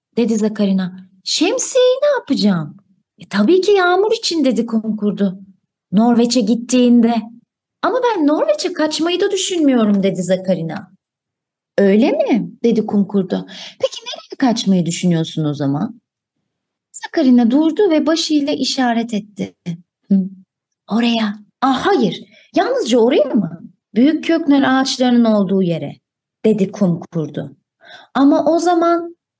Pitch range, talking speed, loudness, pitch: 195-305 Hz, 110 wpm, -16 LUFS, 230 Hz